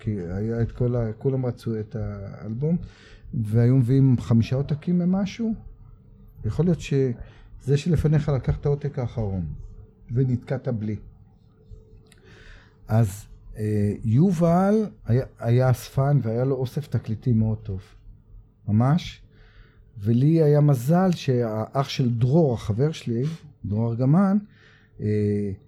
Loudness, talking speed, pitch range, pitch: -23 LUFS, 105 wpm, 110-140 Hz, 115 Hz